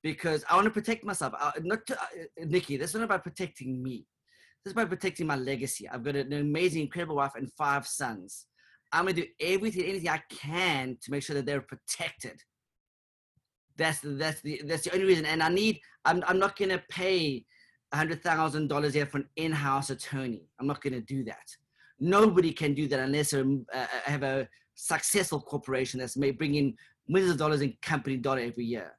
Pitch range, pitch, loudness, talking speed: 135-175 Hz, 150 Hz, -30 LUFS, 195 wpm